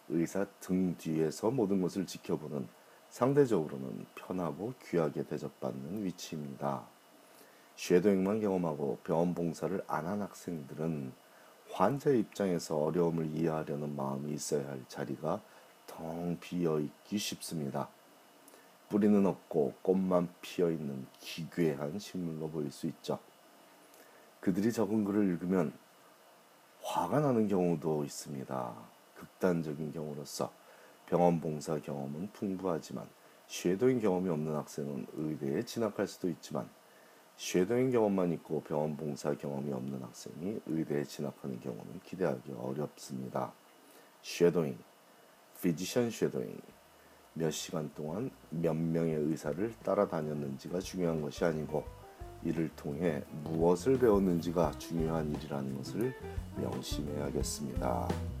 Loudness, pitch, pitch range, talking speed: -34 LUFS, 80 Hz, 75-90 Hz, 285 characters per minute